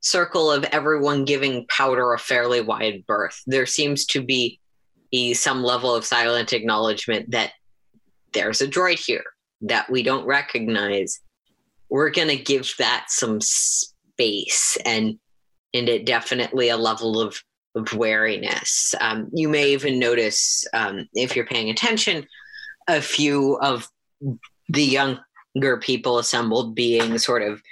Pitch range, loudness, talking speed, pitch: 115-145 Hz, -21 LUFS, 135 wpm, 125 Hz